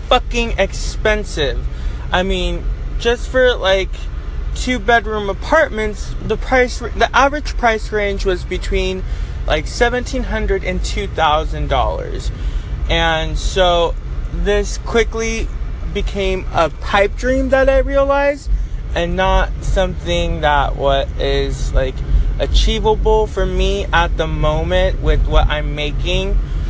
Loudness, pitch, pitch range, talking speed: -17 LUFS, 195 Hz, 145-230 Hz, 110 wpm